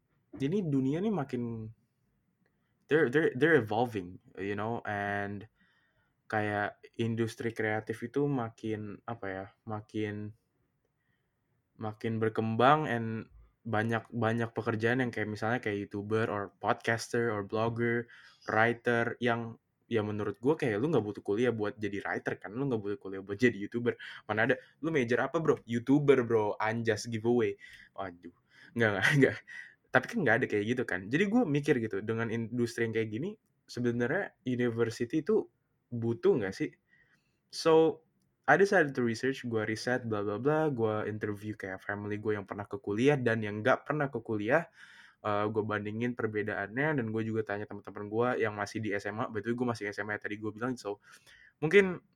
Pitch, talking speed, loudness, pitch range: 115 Hz, 160 wpm, -31 LUFS, 105-125 Hz